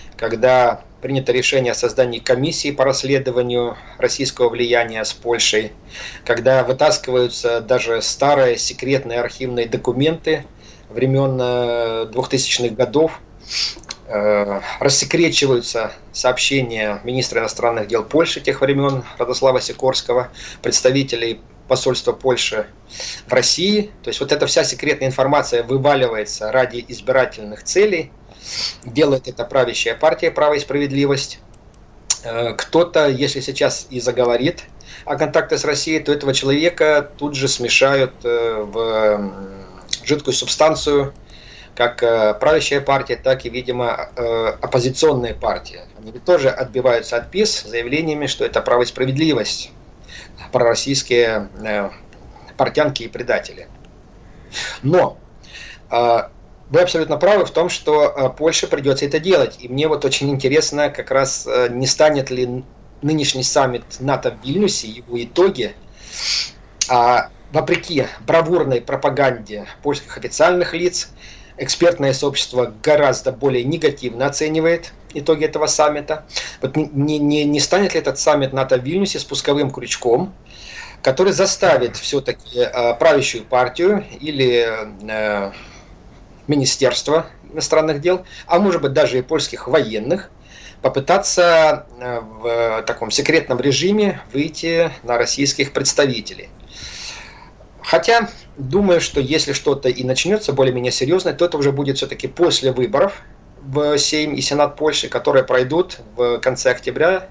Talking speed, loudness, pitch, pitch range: 115 wpm, -17 LUFS, 135 Hz, 120-155 Hz